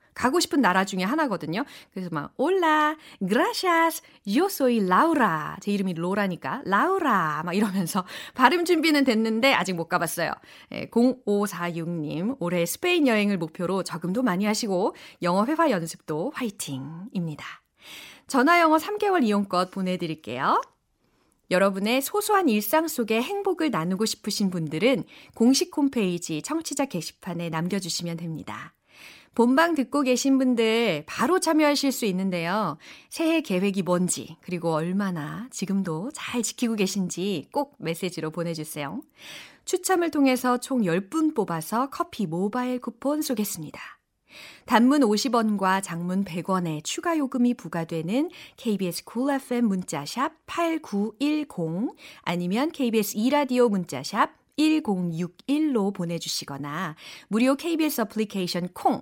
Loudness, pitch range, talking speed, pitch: -25 LUFS, 180-280 Hz, 300 characters per minute, 215 Hz